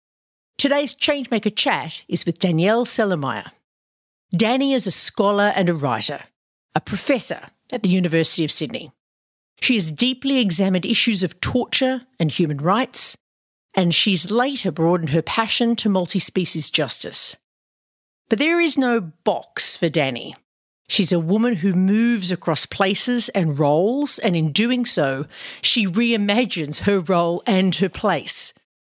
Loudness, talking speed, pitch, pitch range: -19 LUFS, 140 wpm, 195 Hz, 165-235 Hz